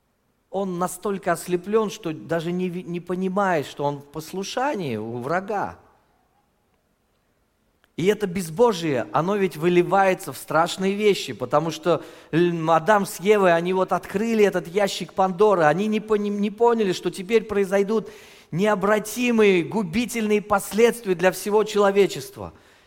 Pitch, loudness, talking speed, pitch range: 190 Hz, -22 LUFS, 120 wpm, 170-210 Hz